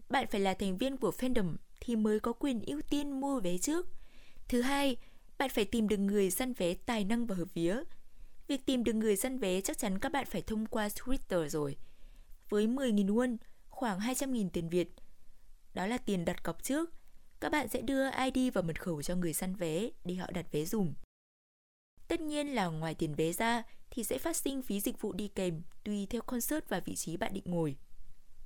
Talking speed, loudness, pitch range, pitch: 210 wpm, -35 LUFS, 180-260 Hz, 220 Hz